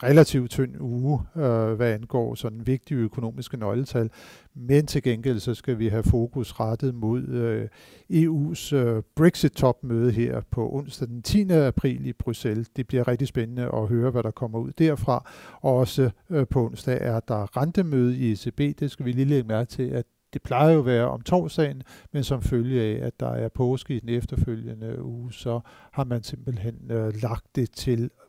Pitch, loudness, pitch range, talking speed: 125 Hz, -25 LUFS, 115-135 Hz, 185 wpm